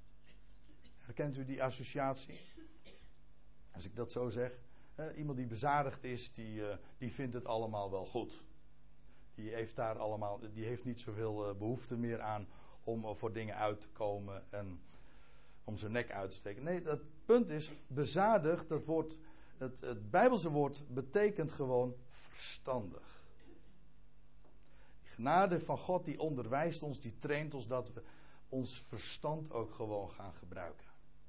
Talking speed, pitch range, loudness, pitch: 155 wpm, 105-145 Hz, -39 LUFS, 125 Hz